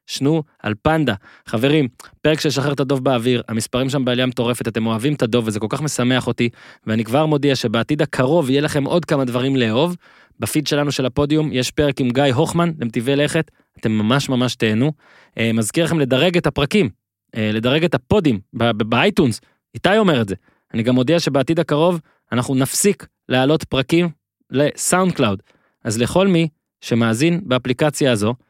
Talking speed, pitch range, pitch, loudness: 170 wpm, 120-155 Hz, 135 Hz, -18 LUFS